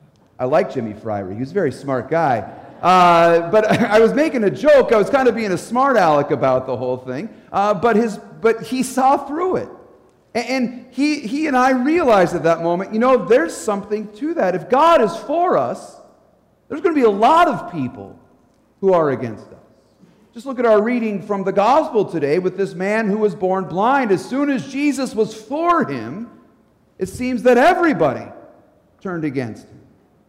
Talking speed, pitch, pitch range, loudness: 195 wpm, 215 Hz, 175-260 Hz, -17 LUFS